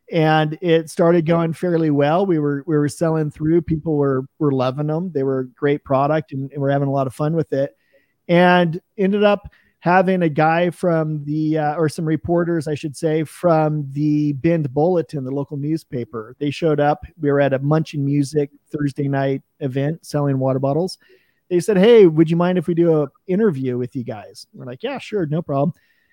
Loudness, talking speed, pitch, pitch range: -19 LUFS, 205 wpm, 155 Hz, 140-170 Hz